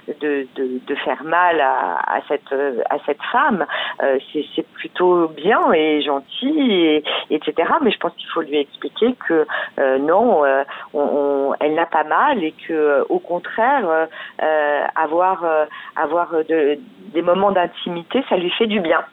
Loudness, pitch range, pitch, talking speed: -19 LUFS, 145-180 Hz, 160 Hz, 175 wpm